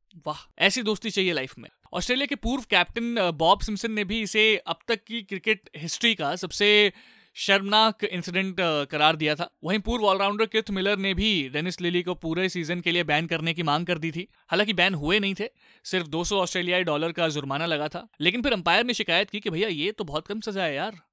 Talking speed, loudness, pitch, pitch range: 215 wpm, -24 LUFS, 190 Hz, 170-215 Hz